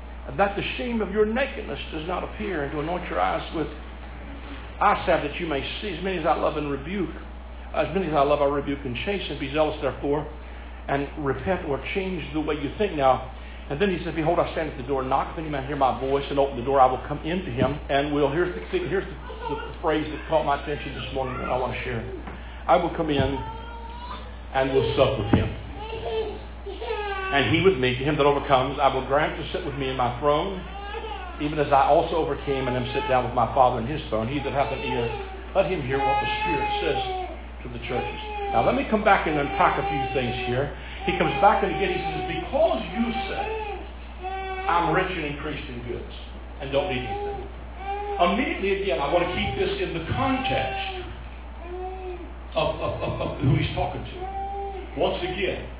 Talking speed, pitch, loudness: 220 wpm, 150 Hz, -25 LUFS